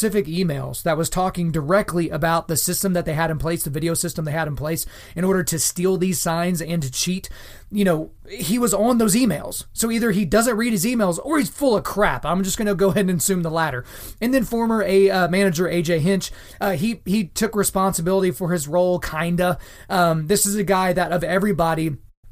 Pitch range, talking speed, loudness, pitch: 165-200 Hz, 225 wpm, -21 LUFS, 180 Hz